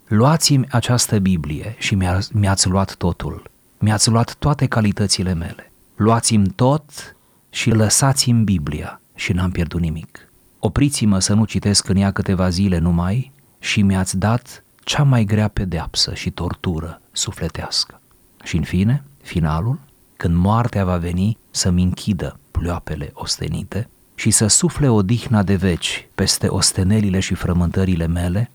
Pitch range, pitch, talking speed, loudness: 90-115 Hz, 100 Hz, 135 wpm, -18 LUFS